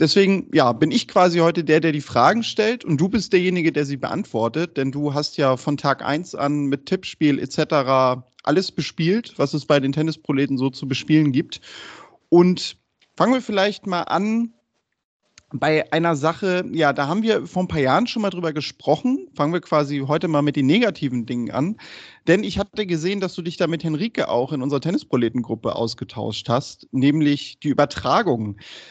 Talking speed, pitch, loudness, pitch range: 185 wpm, 155 Hz, -21 LUFS, 140-180 Hz